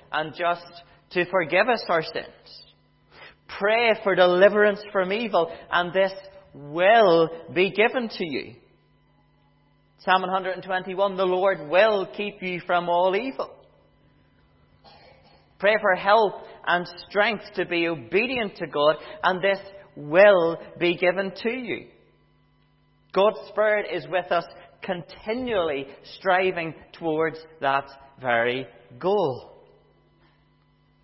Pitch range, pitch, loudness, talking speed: 170-205 Hz, 185 Hz, -23 LUFS, 110 wpm